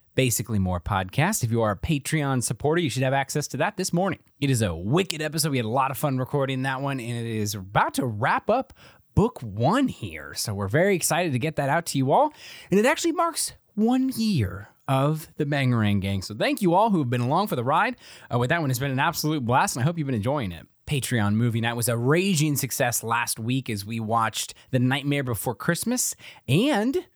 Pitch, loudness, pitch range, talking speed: 135 Hz, -24 LUFS, 115-155 Hz, 235 wpm